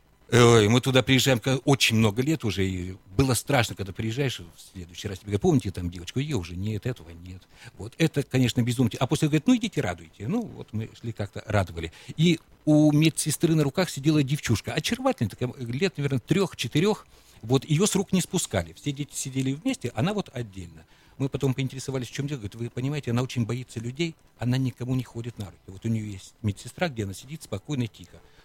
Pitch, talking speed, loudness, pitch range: 125 Hz, 200 wpm, -26 LUFS, 105-145 Hz